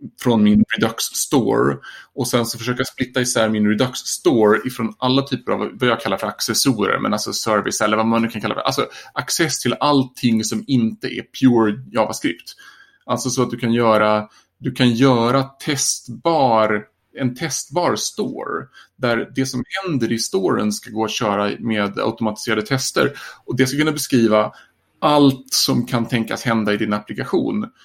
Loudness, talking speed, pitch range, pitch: -19 LUFS, 170 wpm, 110-130 Hz, 120 Hz